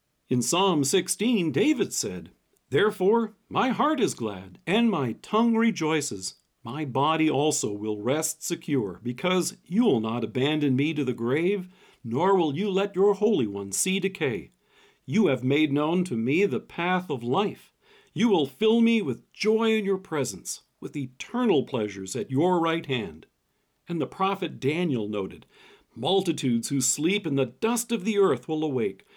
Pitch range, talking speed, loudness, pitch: 130-200 Hz, 165 wpm, -26 LUFS, 165 Hz